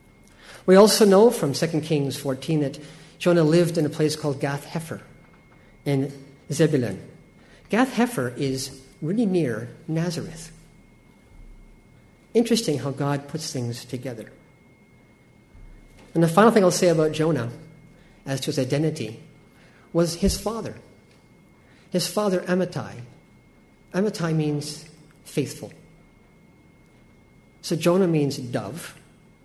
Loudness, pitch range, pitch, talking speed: -23 LUFS, 135-175 Hz, 155 Hz, 110 wpm